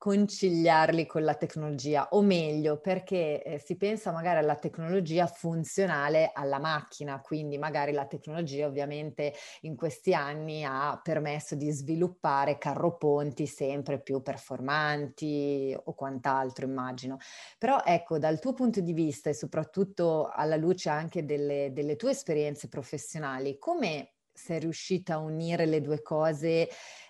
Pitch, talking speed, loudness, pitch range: 155 Hz, 135 wpm, -30 LUFS, 145-165 Hz